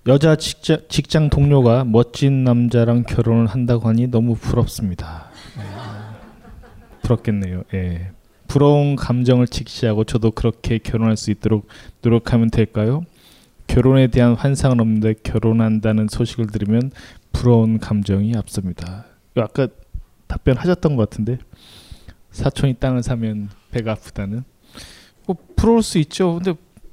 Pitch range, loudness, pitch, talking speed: 110-130 Hz, -18 LUFS, 115 Hz, 285 characters per minute